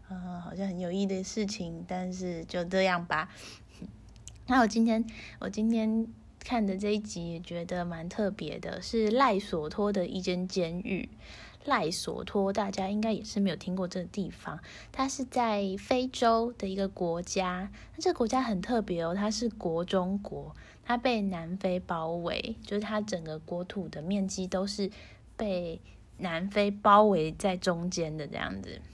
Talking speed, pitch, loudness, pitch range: 240 characters per minute, 190 Hz, -31 LUFS, 180-215 Hz